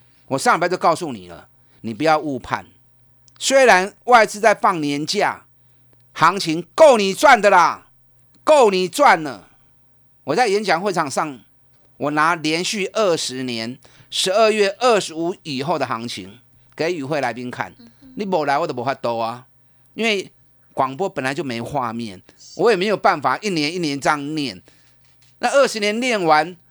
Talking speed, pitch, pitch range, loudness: 230 characters per minute, 150 Hz, 125-190 Hz, -18 LUFS